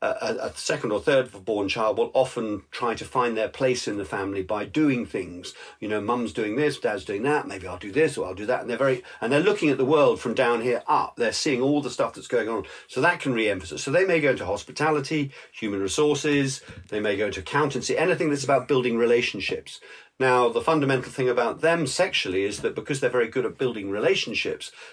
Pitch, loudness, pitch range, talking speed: 130 Hz, -24 LUFS, 110-150 Hz, 230 wpm